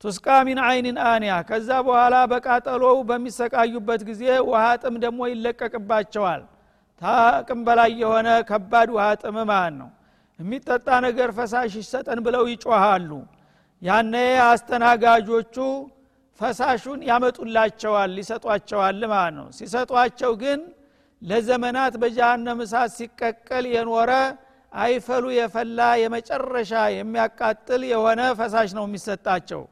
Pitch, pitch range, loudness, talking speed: 235 Hz, 225-250 Hz, -21 LUFS, 95 wpm